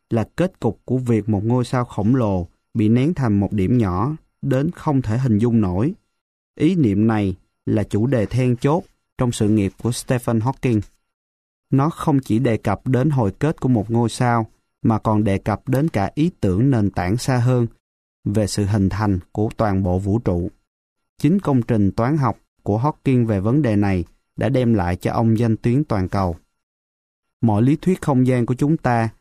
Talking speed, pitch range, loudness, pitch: 200 wpm, 100-130 Hz, -20 LUFS, 115 Hz